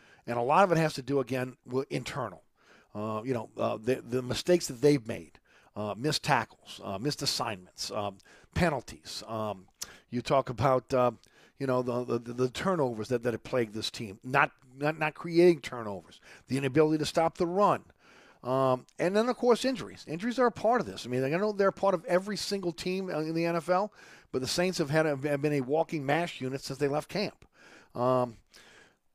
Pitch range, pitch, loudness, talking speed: 120-170 Hz, 135 Hz, -30 LUFS, 205 wpm